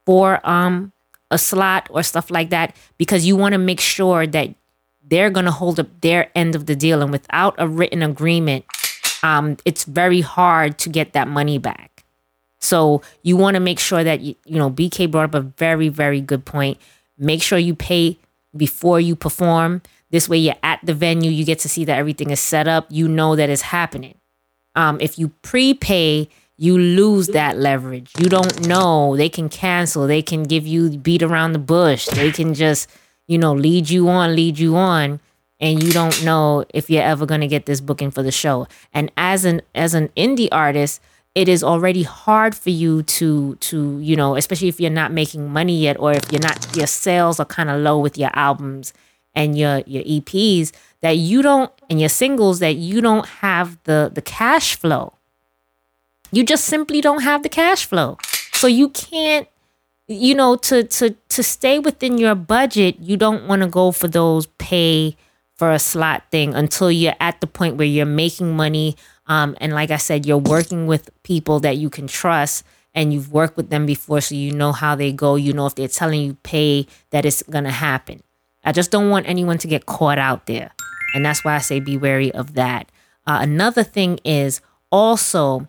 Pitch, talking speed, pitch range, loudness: 160 Hz, 200 wpm, 145-180 Hz, -17 LUFS